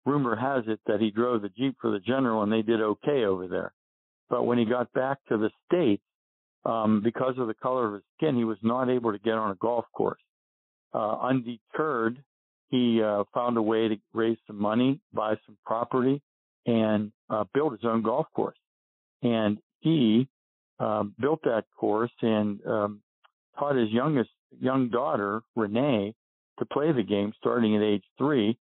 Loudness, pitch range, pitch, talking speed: -27 LUFS, 105-125 Hz, 115 Hz, 180 wpm